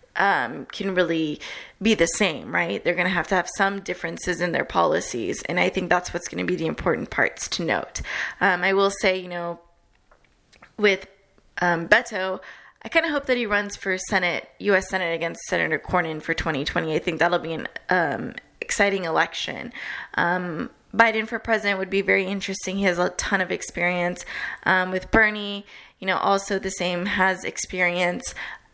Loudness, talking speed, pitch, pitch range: -23 LUFS, 180 wpm, 185 Hz, 175-200 Hz